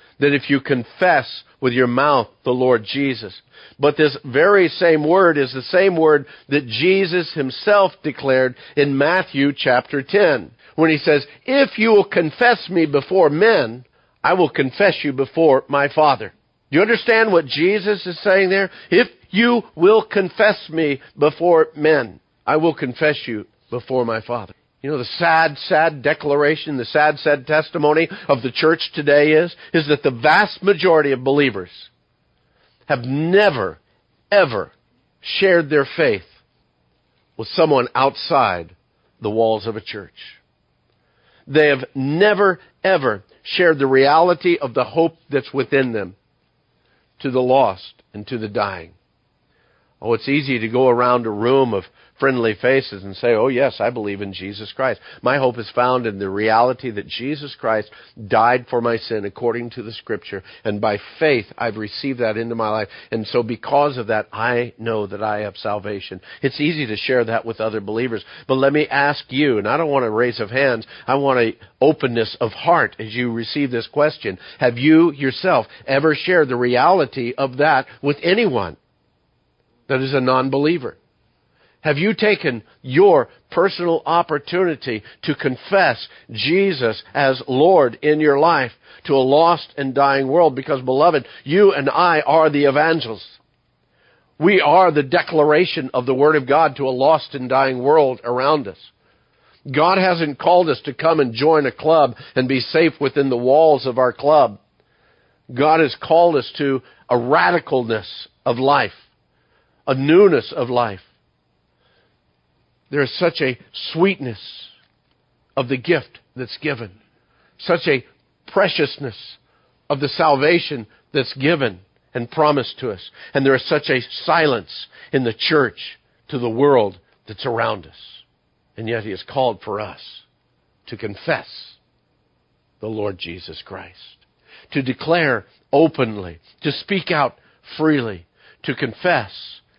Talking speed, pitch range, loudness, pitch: 155 wpm, 120-160 Hz, -18 LUFS, 140 Hz